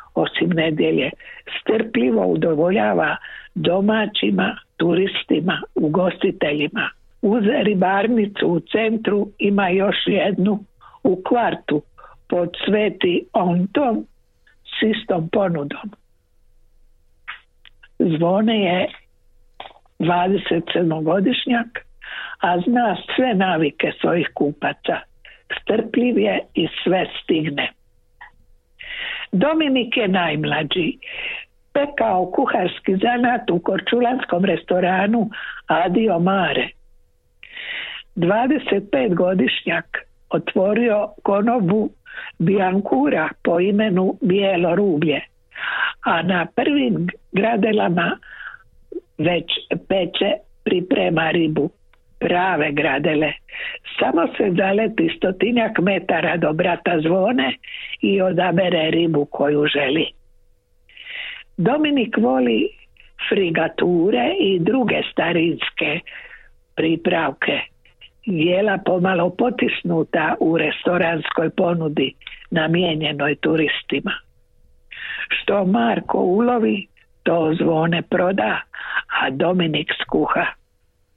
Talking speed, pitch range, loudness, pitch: 75 wpm, 170-230 Hz, -19 LUFS, 190 Hz